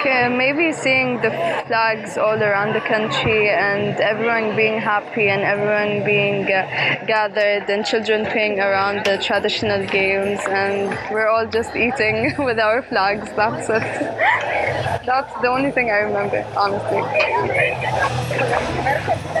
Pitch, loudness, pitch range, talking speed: 210 Hz, -18 LUFS, 200-225 Hz, 125 wpm